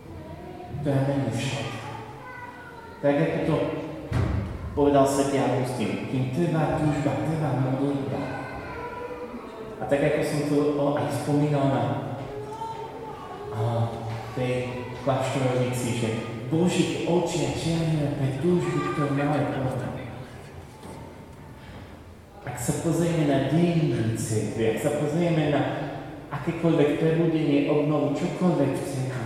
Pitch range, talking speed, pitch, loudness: 130-155 Hz, 105 wpm, 145 Hz, -26 LUFS